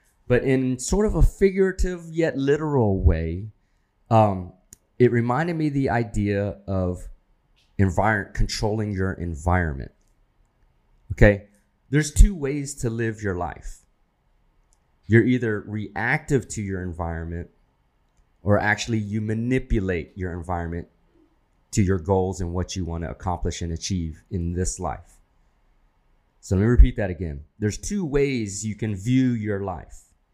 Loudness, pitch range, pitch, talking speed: -24 LUFS, 90-120 Hz, 100 Hz, 135 wpm